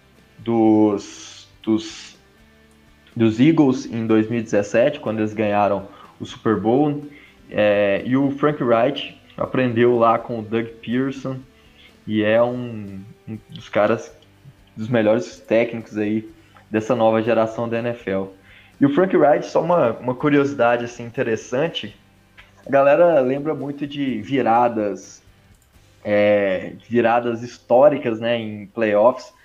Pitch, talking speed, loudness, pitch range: 110 Hz, 120 wpm, -19 LUFS, 100-120 Hz